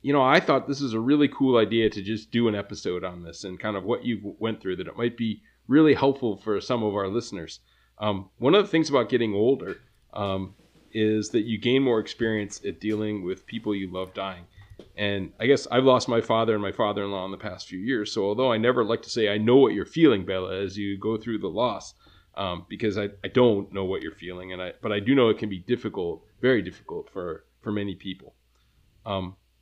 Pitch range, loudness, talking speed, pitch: 95-120 Hz, -25 LUFS, 235 wpm, 105 Hz